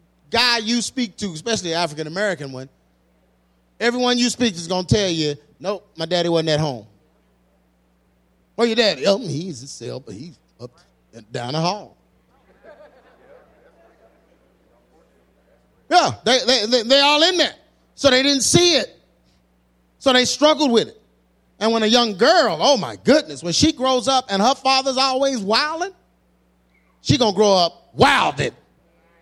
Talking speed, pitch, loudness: 160 wpm, 195 Hz, -18 LUFS